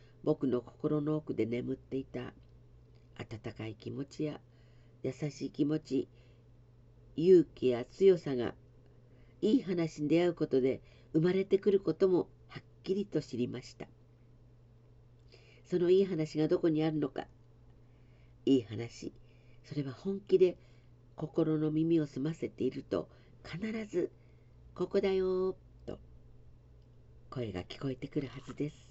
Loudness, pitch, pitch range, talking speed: -33 LUFS, 125 Hz, 120-155 Hz, 230 characters per minute